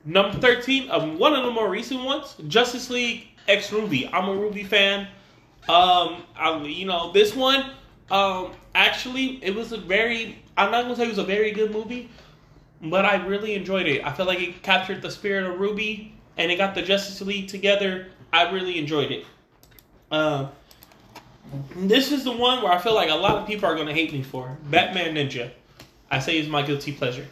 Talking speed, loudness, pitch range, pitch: 200 wpm, -22 LUFS, 160-215 Hz, 195 Hz